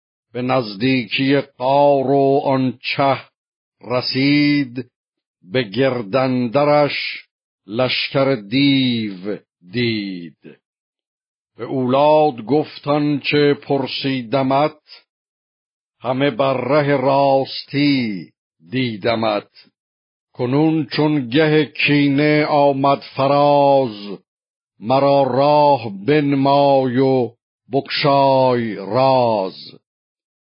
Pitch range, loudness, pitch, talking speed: 125-145 Hz, -17 LUFS, 135 Hz, 65 wpm